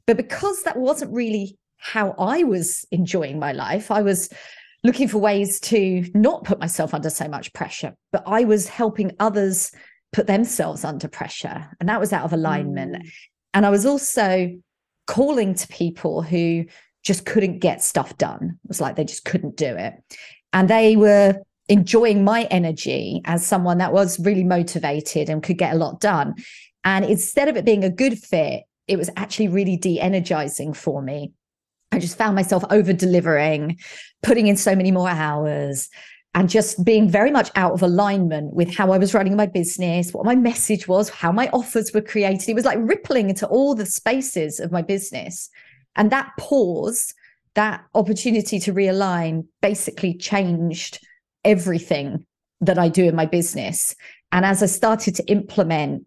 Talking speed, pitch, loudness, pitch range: 175 wpm, 195 Hz, -20 LUFS, 170-215 Hz